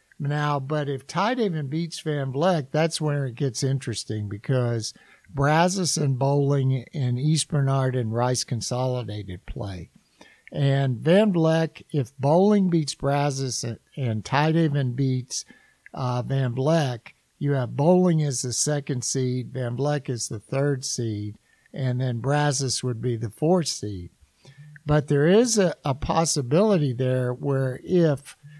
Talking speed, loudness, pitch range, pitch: 145 wpm, -24 LUFS, 125-155 Hz, 140 Hz